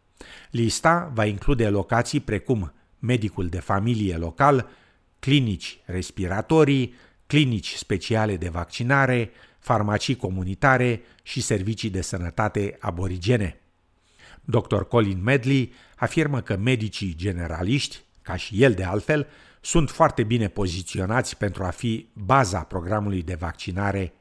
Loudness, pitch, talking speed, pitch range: -24 LUFS, 110 Hz, 110 wpm, 95-125 Hz